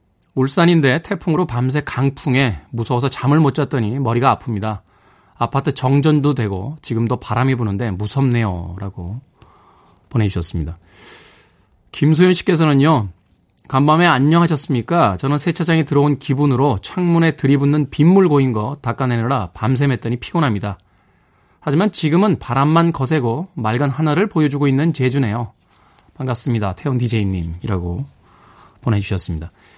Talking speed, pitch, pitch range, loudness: 335 characters per minute, 130 Hz, 105-150 Hz, -17 LUFS